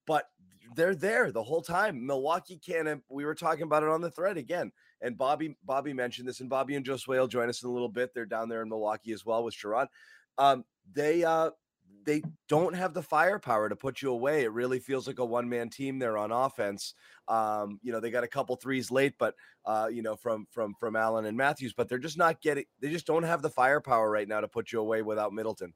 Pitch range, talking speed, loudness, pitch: 115-150 Hz, 240 wpm, -31 LUFS, 125 Hz